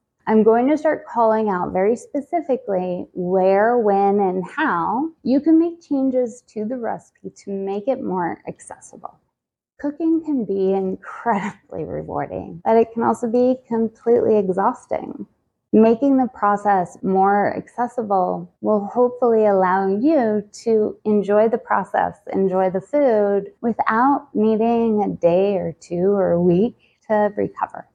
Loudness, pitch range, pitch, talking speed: -19 LUFS, 195-245 Hz, 220 Hz, 135 wpm